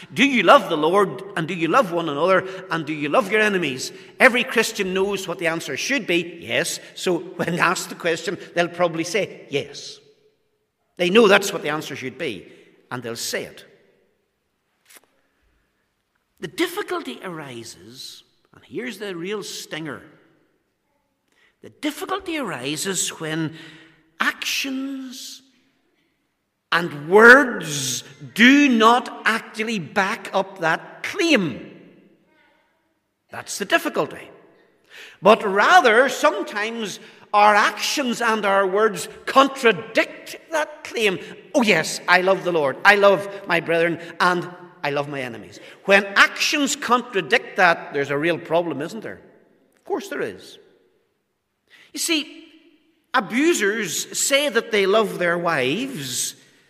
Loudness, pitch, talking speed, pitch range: -20 LUFS, 200 Hz, 130 wpm, 170-275 Hz